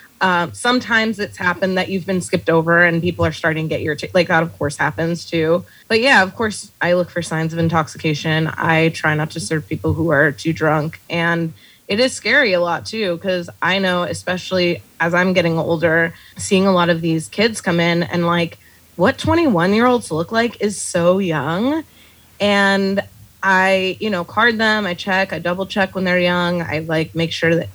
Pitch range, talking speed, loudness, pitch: 165-195 Hz, 210 wpm, -17 LUFS, 175 Hz